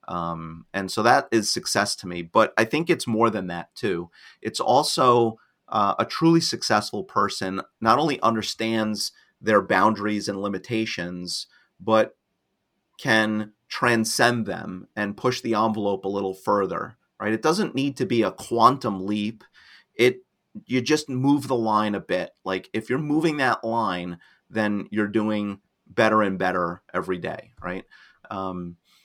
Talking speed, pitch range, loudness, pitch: 155 wpm, 95-120 Hz, -24 LUFS, 110 Hz